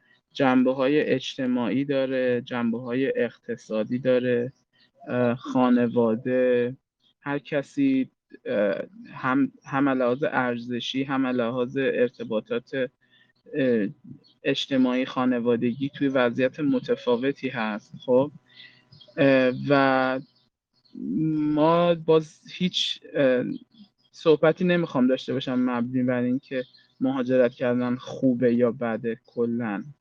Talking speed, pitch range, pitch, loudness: 85 wpm, 125-155 Hz, 130 Hz, -25 LUFS